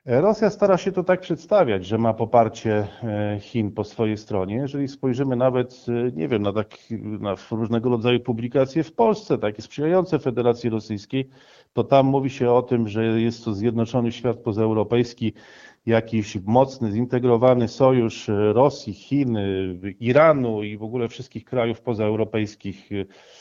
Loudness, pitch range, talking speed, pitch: -22 LUFS, 110-130 Hz, 140 wpm, 120 Hz